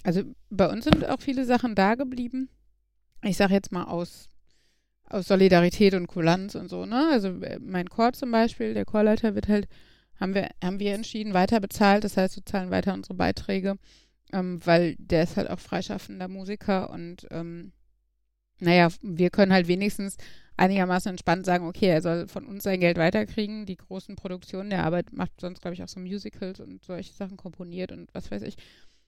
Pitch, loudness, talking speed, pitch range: 190 Hz, -25 LUFS, 185 wpm, 175-205 Hz